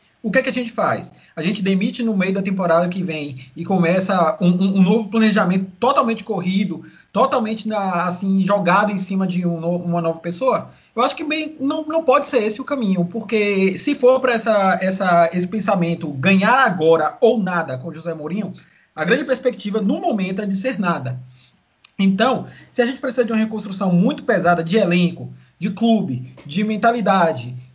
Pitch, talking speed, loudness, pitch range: 195 Hz, 190 wpm, -19 LUFS, 175-225 Hz